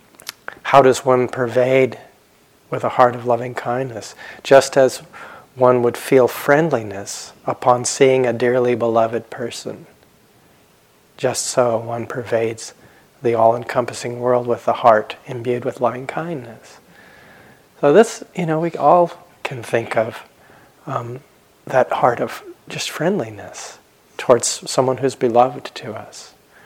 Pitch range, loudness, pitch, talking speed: 120-135 Hz, -18 LUFS, 125 Hz, 130 wpm